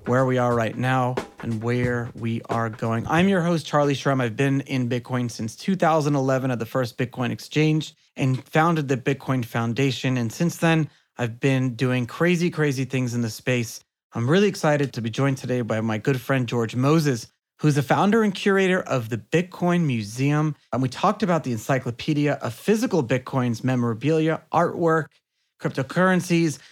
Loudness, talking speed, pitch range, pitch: -23 LUFS, 175 wpm, 120-160 Hz, 135 Hz